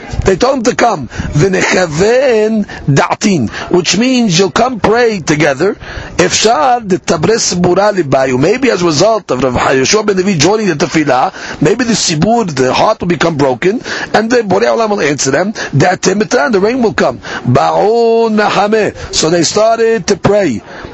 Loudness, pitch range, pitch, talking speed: -11 LUFS, 175-225 Hz, 200 Hz, 160 wpm